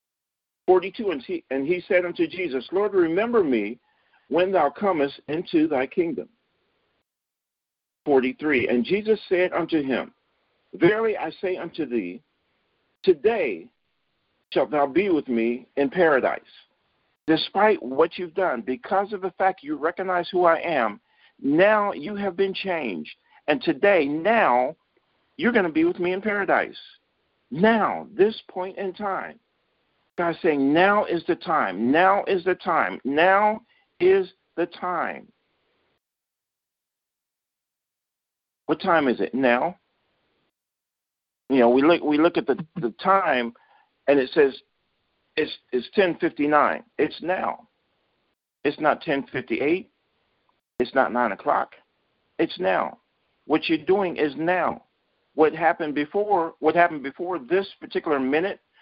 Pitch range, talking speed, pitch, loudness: 150-205 Hz, 135 wpm, 180 Hz, -23 LUFS